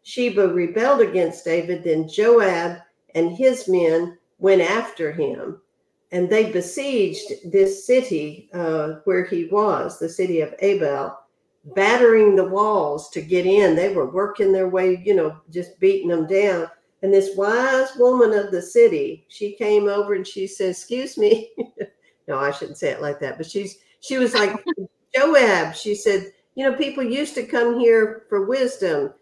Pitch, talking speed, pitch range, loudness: 200 Hz, 165 wpm, 175-245 Hz, -20 LUFS